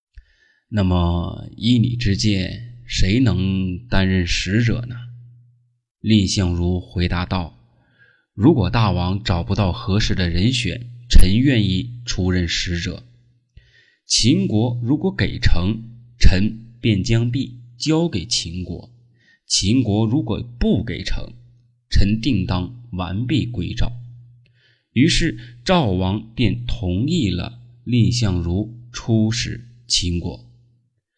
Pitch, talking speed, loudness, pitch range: 110 Hz, 155 characters per minute, -20 LUFS, 95-120 Hz